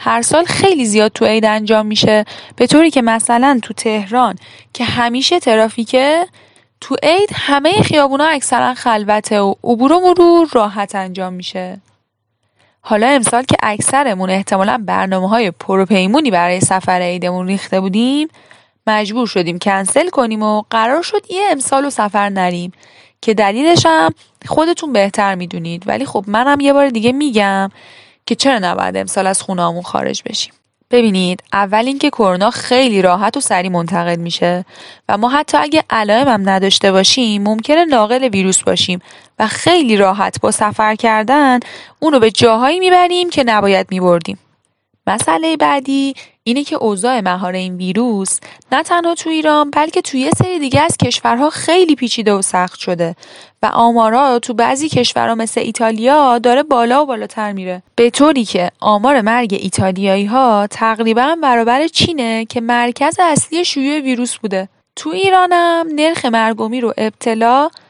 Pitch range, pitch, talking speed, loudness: 195-275 Hz, 230 Hz, 150 wpm, -13 LUFS